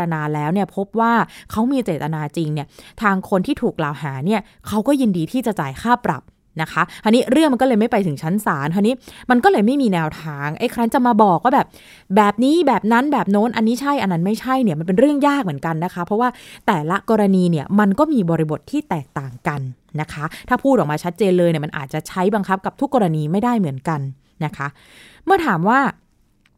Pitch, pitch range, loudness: 200 Hz, 160-235 Hz, -18 LUFS